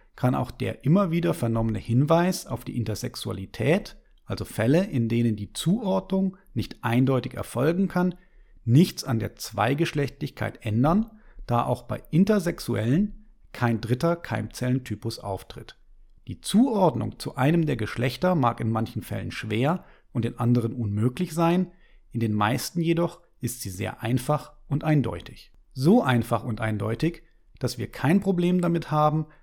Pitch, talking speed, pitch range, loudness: 130 Hz, 140 wpm, 115-170 Hz, -26 LUFS